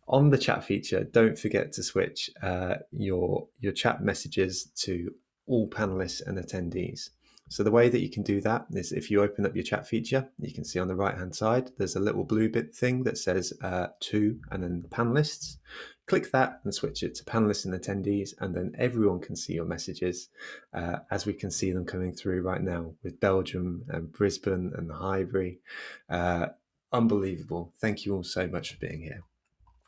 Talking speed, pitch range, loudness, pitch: 195 wpm, 90-110 Hz, -30 LUFS, 95 Hz